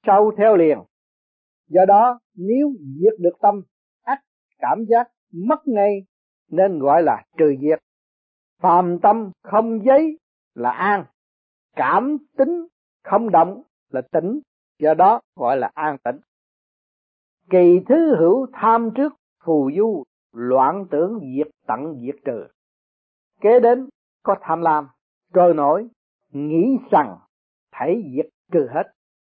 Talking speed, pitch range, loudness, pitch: 130 wpm, 155-240 Hz, -19 LUFS, 200 Hz